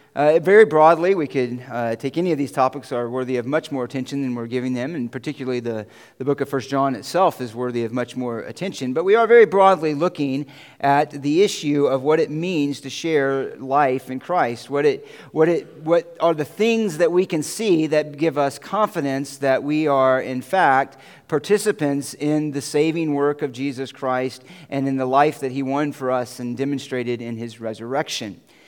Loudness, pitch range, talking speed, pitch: -21 LUFS, 130-160 Hz, 205 wpm, 140 Hz